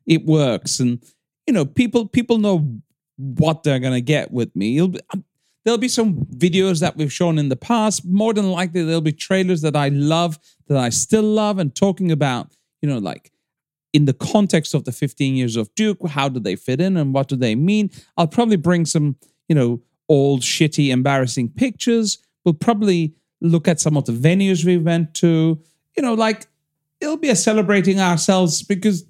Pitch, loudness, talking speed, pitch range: 165 Hz, -18 LUFS, 195 wpm, 145-195 Hz